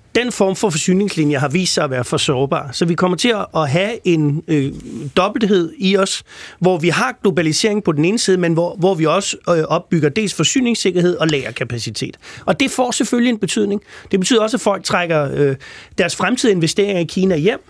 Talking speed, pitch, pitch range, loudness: 205 wpm, 180 Hz, 160-210 Hz, -16 LUFS